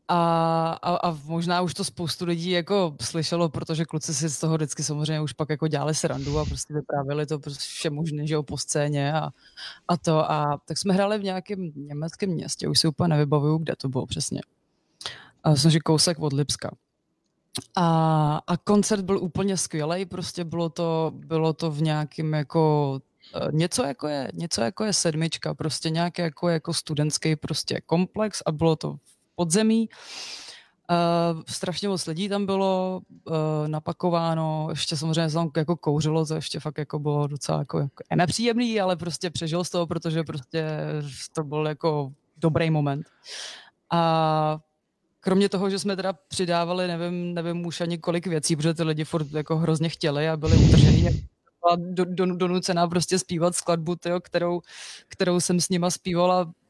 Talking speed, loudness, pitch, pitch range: 165 wpm, -25 LUFS, 165 Hz, 155-175 Hz